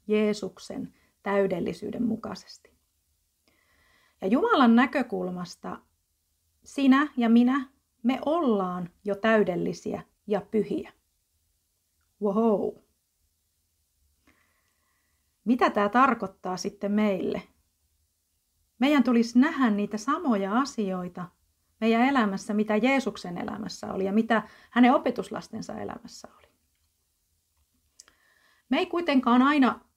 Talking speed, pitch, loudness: 85 wpm, 205 Hz, -26 LUFS